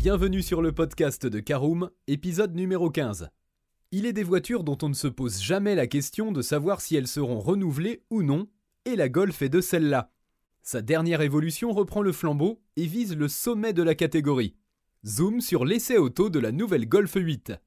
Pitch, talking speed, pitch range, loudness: 165 Hz, 195 wpm, 145-195 Hz, -26 LUFS